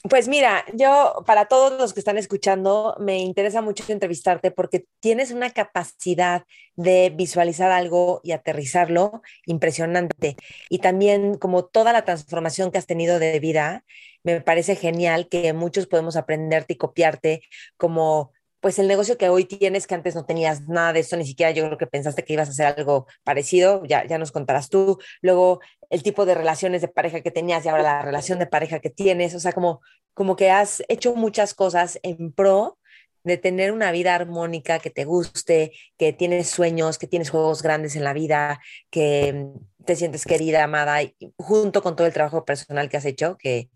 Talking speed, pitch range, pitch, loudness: 185 wpm, 160-190 Hz, 175 Hz, -21 LUFS